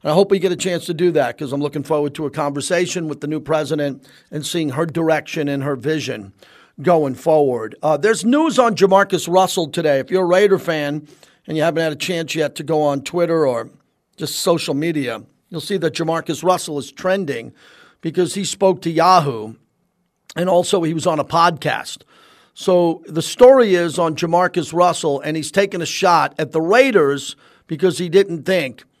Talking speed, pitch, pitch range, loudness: 195 wpm, 165 Hz, 150-180 Hz, -17 LUFS